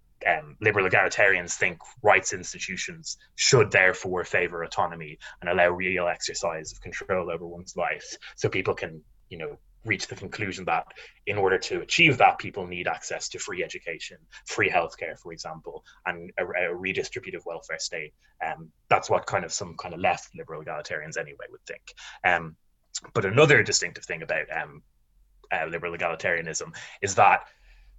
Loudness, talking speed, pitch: -25 LUFS, 165 wpm, 90 Hz